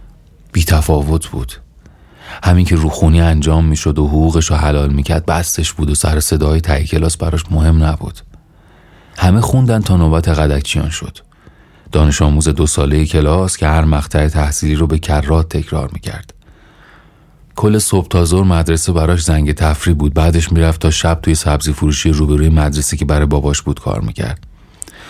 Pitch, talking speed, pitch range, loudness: 80 Hz, 165 wpm, 75-85 Hz, -13 LUFS